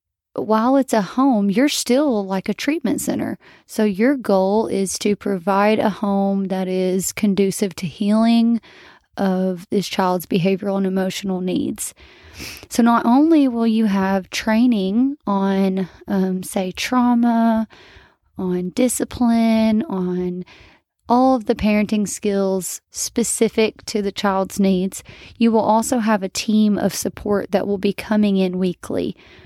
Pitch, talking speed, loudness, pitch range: 205 Hz, 140 wpm, -19 LUFS, 190-230 Hz